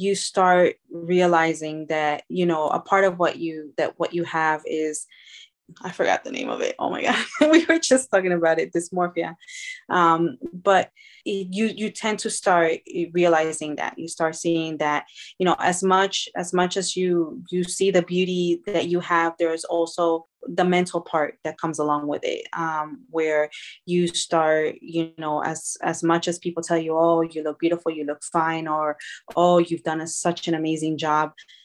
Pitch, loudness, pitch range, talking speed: 170 Hz, -23 LUFS, 160-180 Hz, 190 wpm